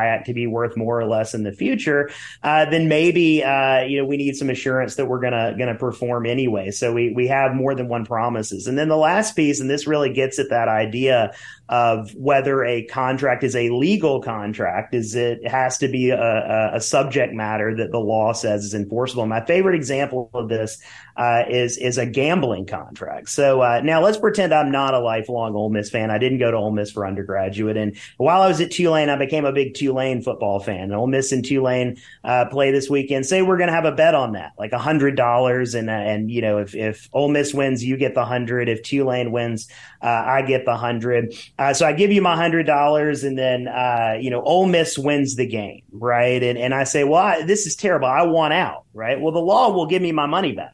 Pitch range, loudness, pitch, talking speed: 115-140 Hz, -20 LUFS, 125 Hz, 230 wpm